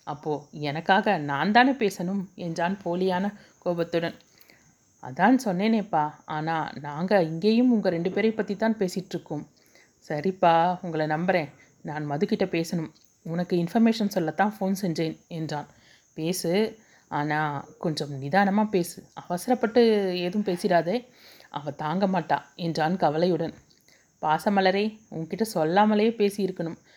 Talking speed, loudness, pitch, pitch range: 105 wpm, -26 LUFS, 180 Hz, 160-205 Hz